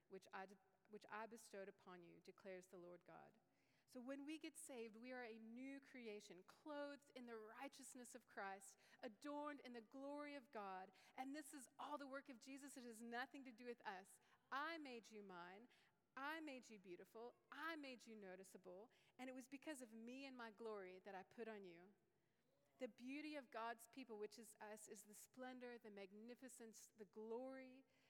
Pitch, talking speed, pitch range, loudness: 235 Hz, 190 wpm, 210-265 Hz, -58 LUFS